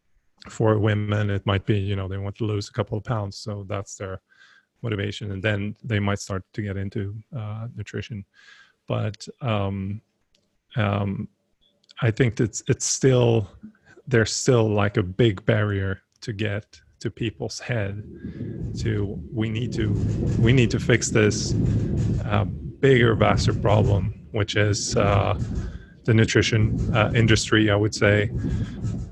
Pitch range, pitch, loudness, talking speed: 100-115 Hz, 105 Hz, -23 LUFS, 145 wpm